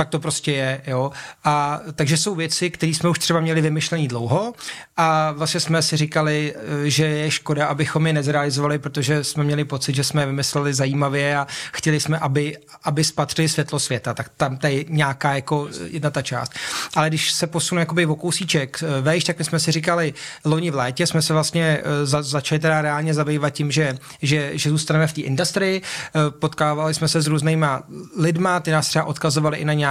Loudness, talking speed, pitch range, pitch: -21 LUFS, 195 wpm, 145-160 Hz, 155 Hz